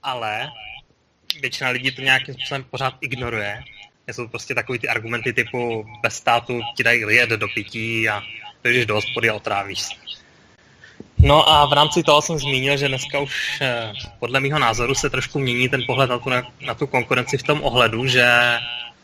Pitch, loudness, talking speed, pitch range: 125 Hz, -19 LUFS, 175 wpm, 120-140 Hz